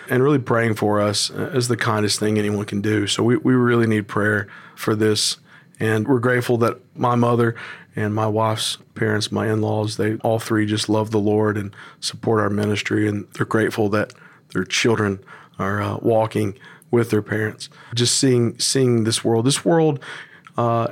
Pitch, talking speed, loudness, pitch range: 110 Hz, 185 wpm, -20 LUFS, 105-120 Hz